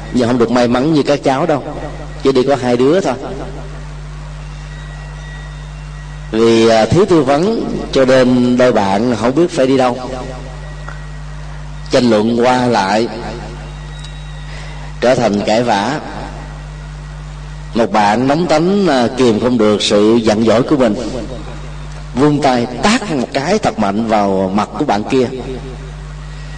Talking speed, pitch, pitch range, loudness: 135 wpm, 145 Hz, 125-150 Hz, -13 LUFS